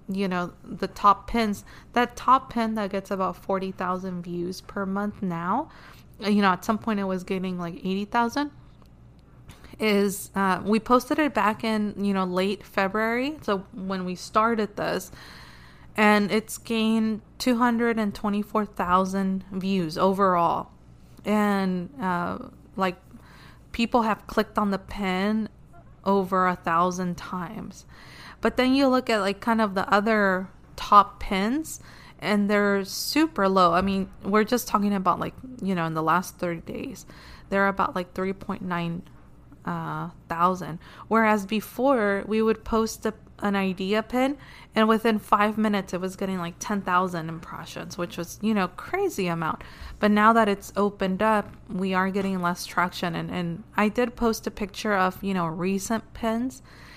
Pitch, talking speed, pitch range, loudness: 200 Hz, 165 wpm, 185-220 Hz, -25 LUFS